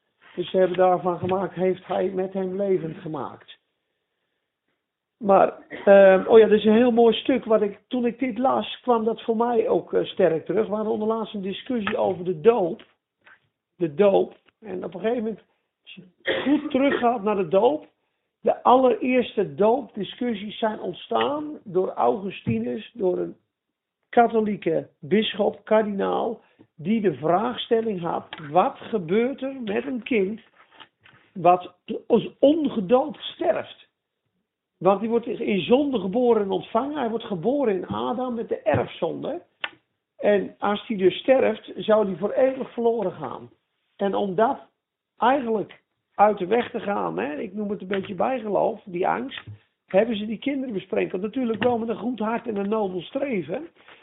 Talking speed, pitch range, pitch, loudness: 160 wpm, 195-240 Hz, 220 Hz, -23 LUFS